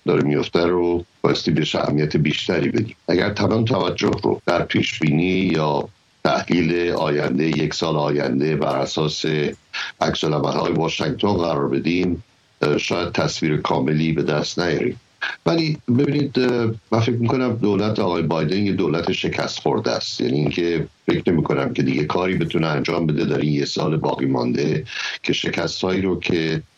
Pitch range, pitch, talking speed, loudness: 75-105 Hz, 85 Hz, 150 wpm, -20 LUFS